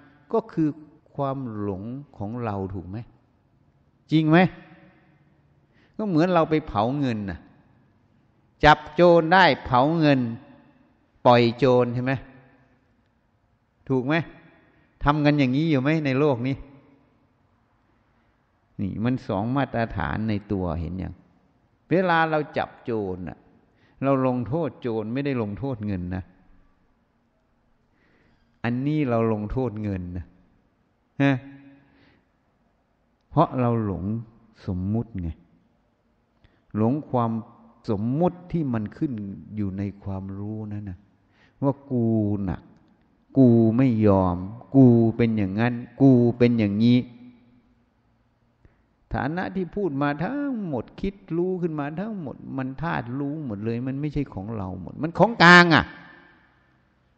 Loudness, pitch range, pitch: -23 LUFS, 105-145 Hz, 120 Hz